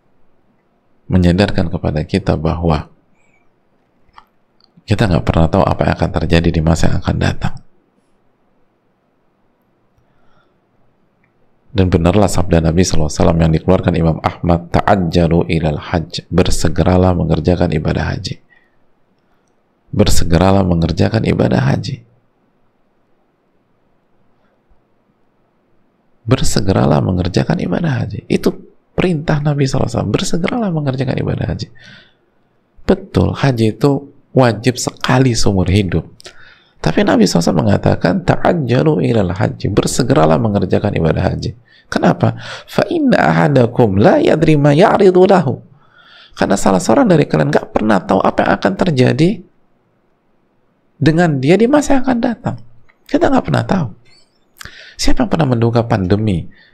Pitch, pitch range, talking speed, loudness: 100 Hz, 85-130 Hz, 110 wpm, -14 LUFS